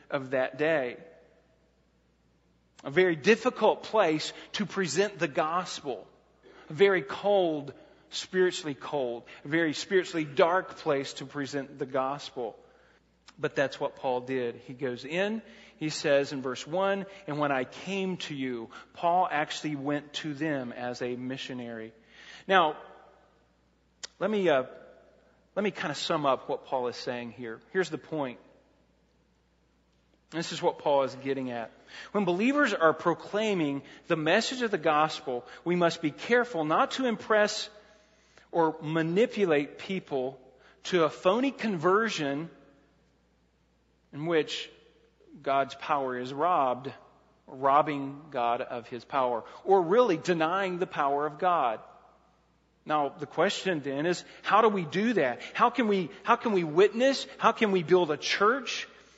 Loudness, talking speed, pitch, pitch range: -29 LUFS, 145 wpm, 155 Hz, 135-190 Hz